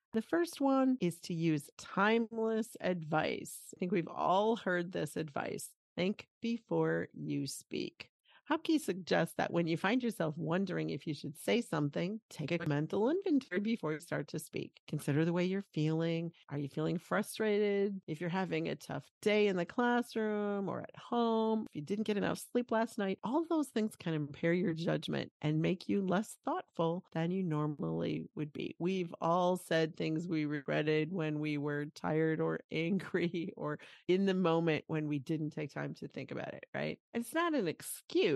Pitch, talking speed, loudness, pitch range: 175 Hz, 185 wpm, -35 LUFS, 155-210 Hz